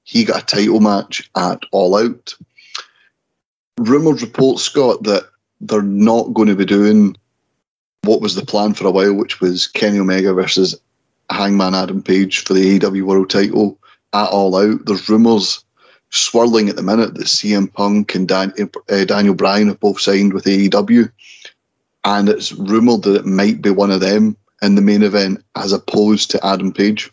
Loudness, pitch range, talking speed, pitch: -14 LUFS, 95-105 Hz, 175 wpm, 100 Hz